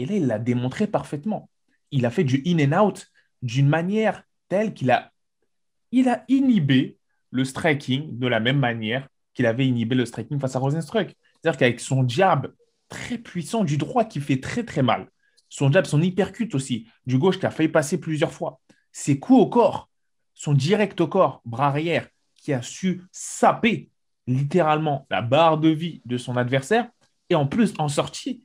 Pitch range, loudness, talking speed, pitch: 130-190 Hz, -23 LUFS, 185 wpm, 155 Hz